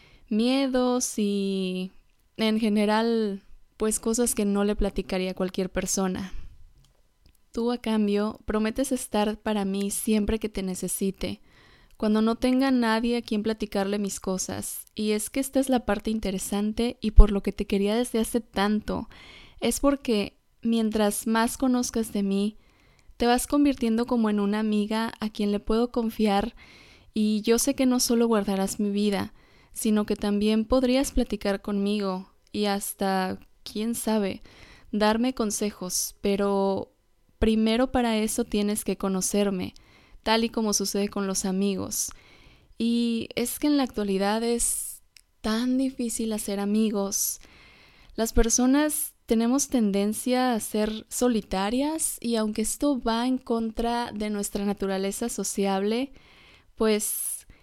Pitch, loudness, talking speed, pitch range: 215 Hz, -26 LUFS, 140 wpm, 200-235 Hz